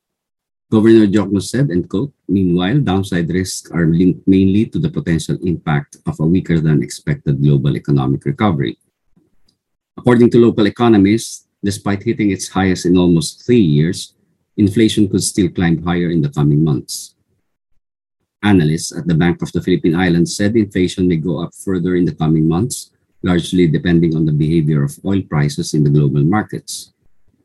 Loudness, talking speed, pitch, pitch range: -15 LUFS, 160 wpm, 90 Hz, 80-100 Hz